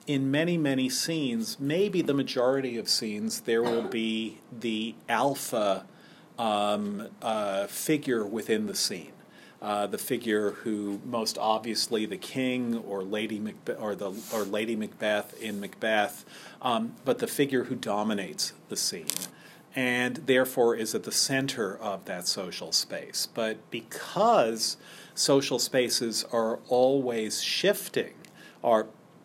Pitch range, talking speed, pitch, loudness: 110-135 Hz, 130 wpm, 120 Hz, -28 LUFS